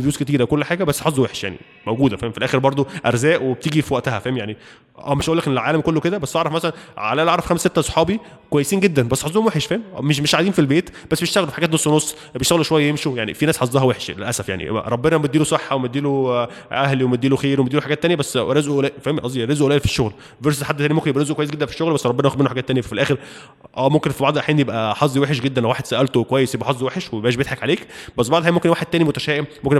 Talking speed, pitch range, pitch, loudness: 245 wpm, 130-160 Hz, 145 Hz, -19 LUFS